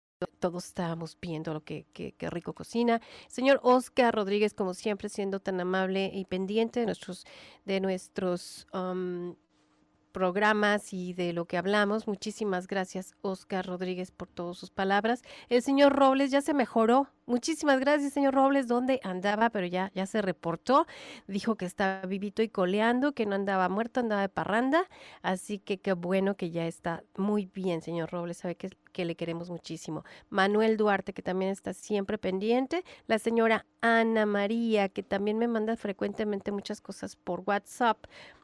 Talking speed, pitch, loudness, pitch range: 165 wpm, 200 Hz, -30 LUFS, 185-230 Hz